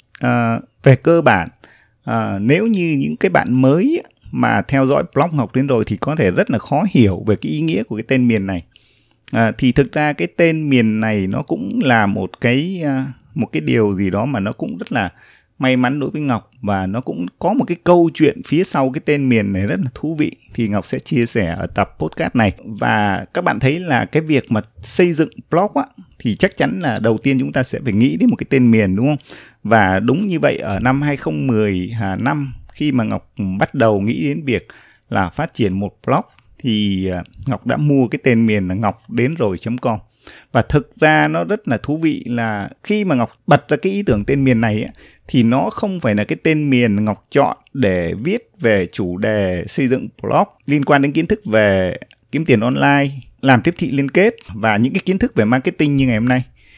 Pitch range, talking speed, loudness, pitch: 110-150 Hz, 230 wpm, -17 LUFS, 125 Hz